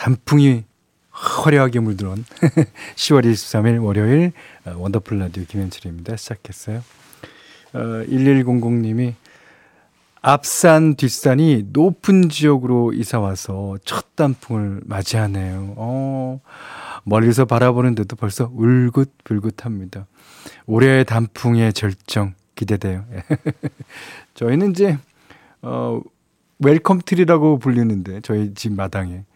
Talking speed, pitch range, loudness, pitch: 230 characters per minute, 105-135 Hz, -18 LUFS, 115 Hz